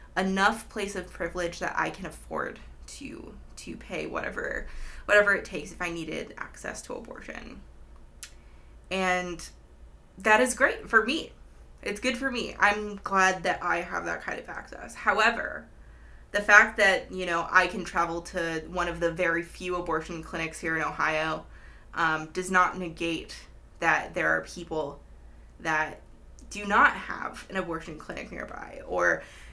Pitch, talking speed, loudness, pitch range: 175 Hz, 155 wpm, -27 LUFS, 160-190 Hz